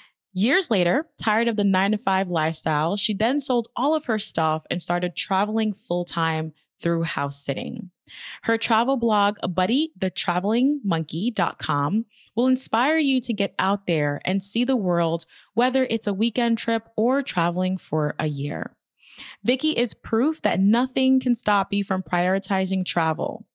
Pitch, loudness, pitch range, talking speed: 200 Hz, -23 LUFS, 175-235 Hz, 150 wpm